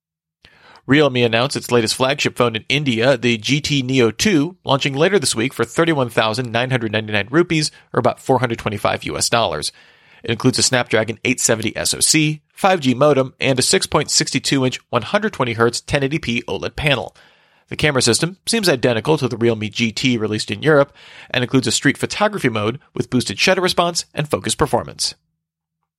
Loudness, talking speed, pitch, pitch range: -17 LUFS, 150 wpm, 125 Hz, 115-145 Hz